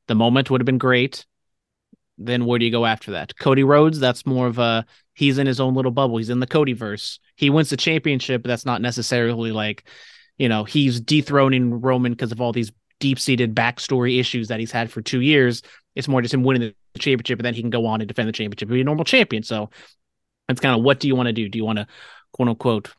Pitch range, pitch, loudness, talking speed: 115-135 Hz, 125 Hz, -20 LUFS, 250 wpm